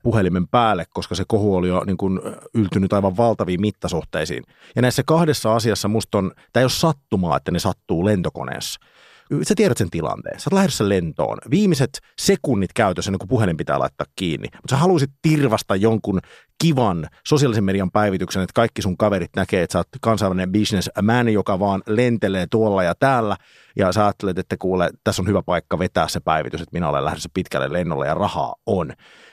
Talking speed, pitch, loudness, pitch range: 185 wpm, 105 Hz, -20 LUFS, 95-115 Hz